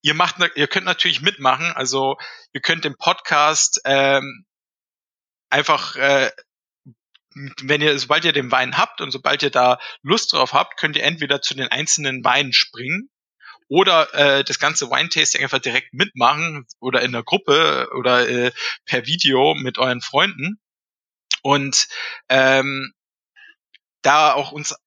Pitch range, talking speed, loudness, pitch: 130-155 Hz, 145 wpm, -17 LUFS, 140 Hz